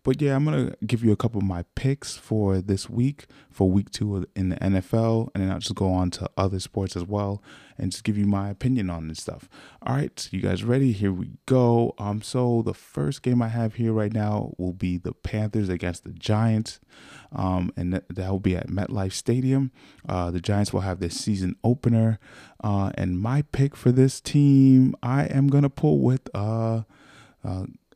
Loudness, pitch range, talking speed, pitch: -25 LUFS, 95-125 Hz, 215 wpm, 105 Hz